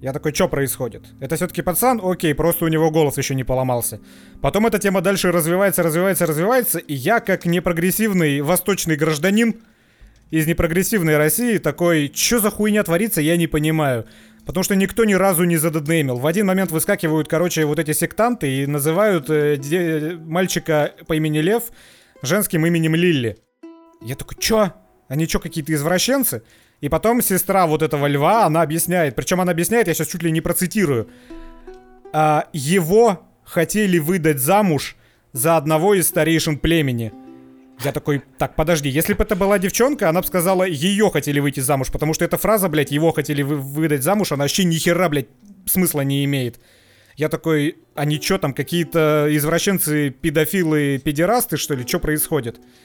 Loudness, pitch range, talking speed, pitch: -18 LUFS, 145-185 Hz, 165 wpm, 160 Hz